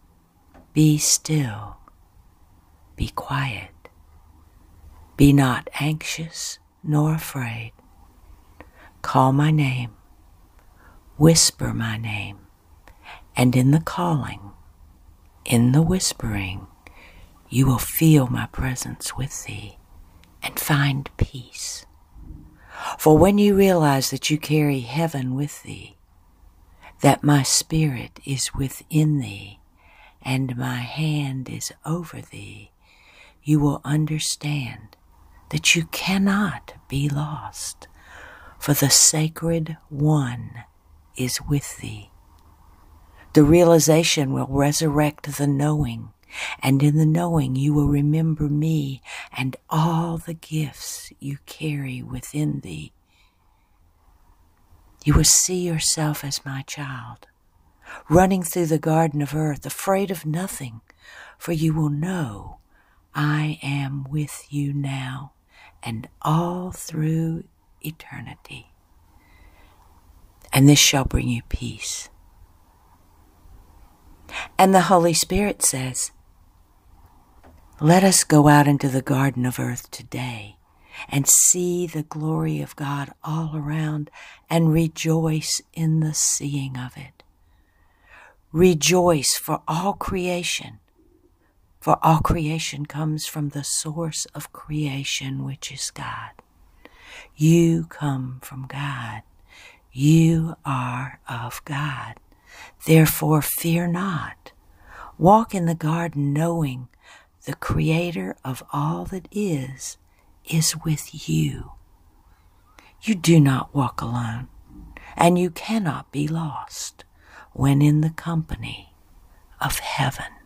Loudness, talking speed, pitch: -21 LUFS, 105 wpm, 140 Hz